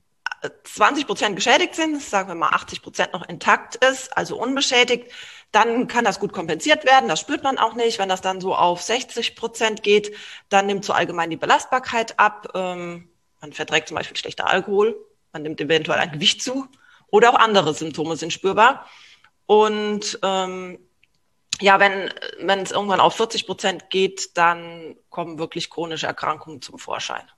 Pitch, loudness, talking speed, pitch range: 195 Hz, -20 LUFS, 165 wpm, 170-240 Hz